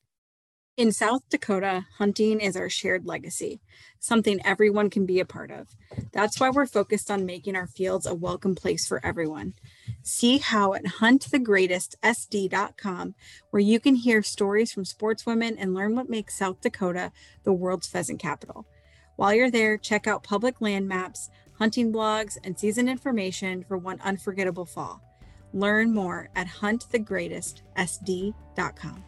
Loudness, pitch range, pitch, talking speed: -26 LUFS, 185-220 Hz, 200 Hz, 145 wpm